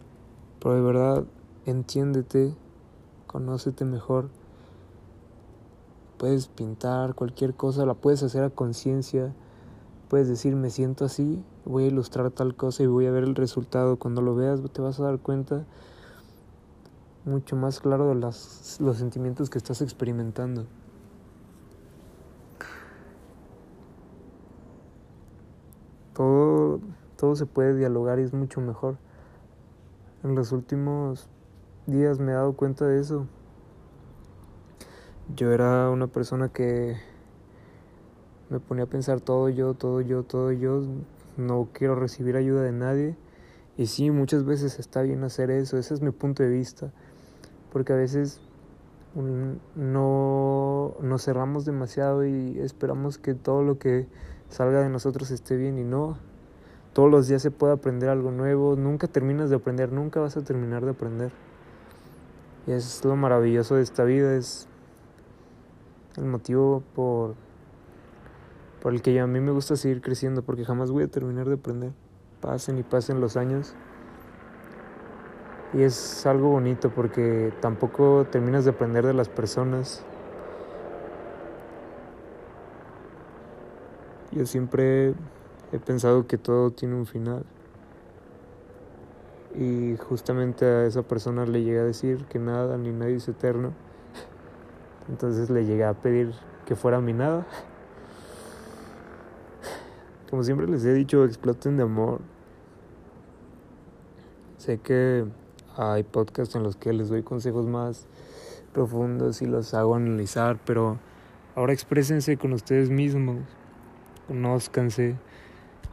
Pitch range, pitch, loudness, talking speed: 120-135 Hz, 130 Hz, -26 LUFS, 130 wpm